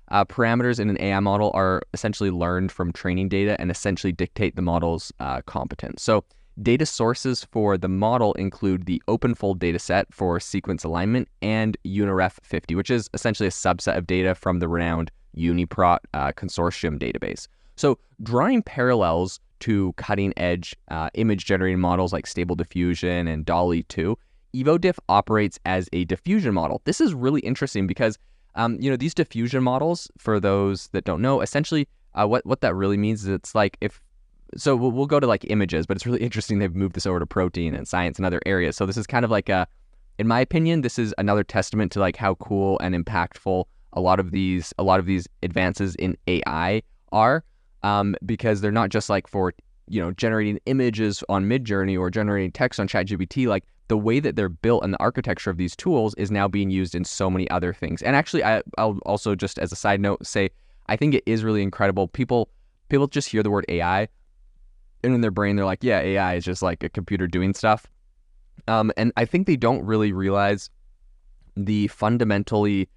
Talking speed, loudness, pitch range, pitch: 195 wpm, -23 LUFS, 90-110 Hz, 100 Hz